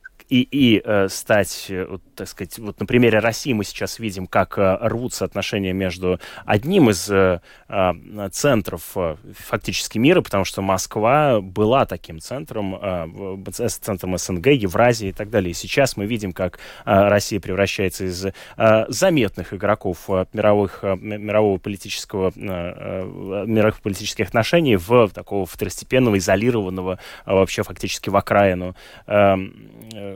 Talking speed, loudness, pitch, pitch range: 150 wpm, -20 LUFS, 100 Hz, 95-110 Hz